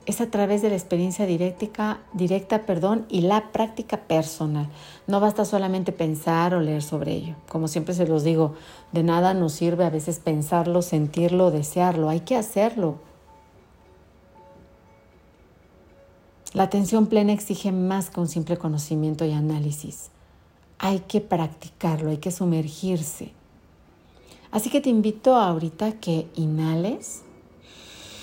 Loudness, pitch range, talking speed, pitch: -24 LUFS, 155-200 Hz, 130 wpm, 170 Hz